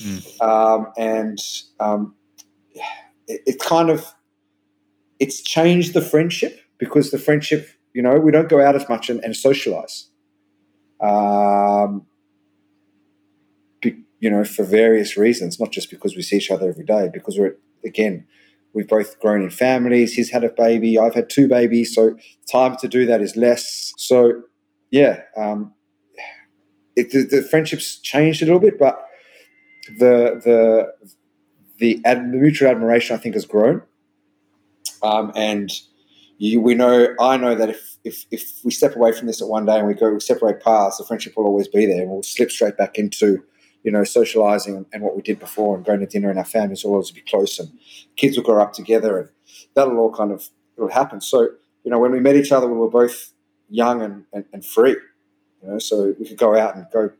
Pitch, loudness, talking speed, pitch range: 110 Hz, -18 LUFS, 190 wpm, 100-125 Hz